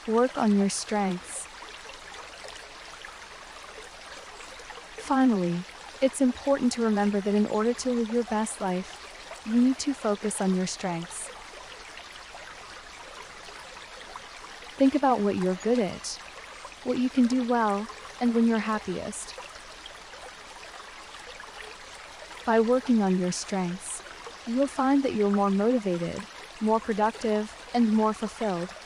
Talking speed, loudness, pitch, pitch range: 115 wpm, -27 LUFS, 220 Hz, 200-245 Hz